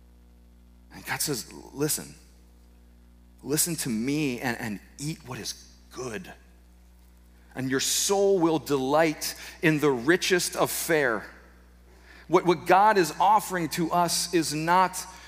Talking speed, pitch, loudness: 120 wpm, 135 Hz, -25 LUFS